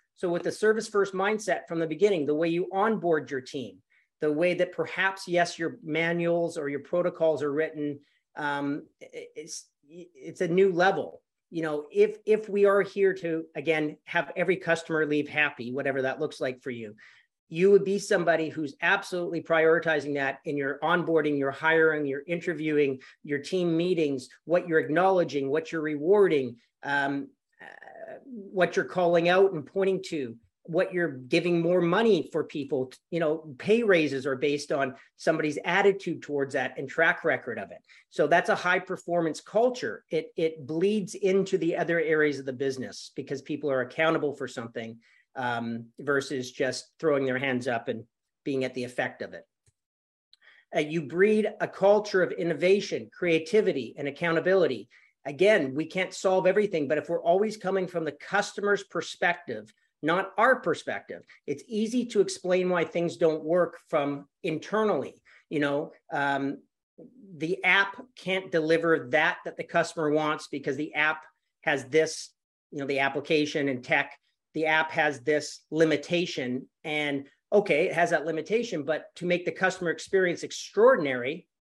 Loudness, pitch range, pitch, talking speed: -27 LUFS, 145-185 Hz, 165 Hz, 165 wpm